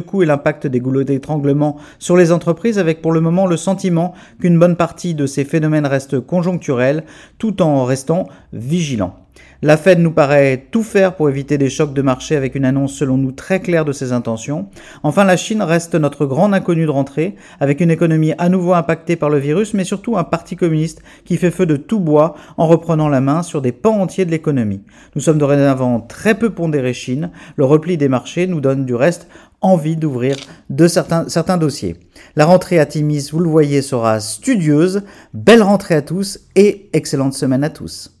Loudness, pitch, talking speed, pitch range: -15 LUFS, 155 Hz, 200 wpm, 140-180 Hz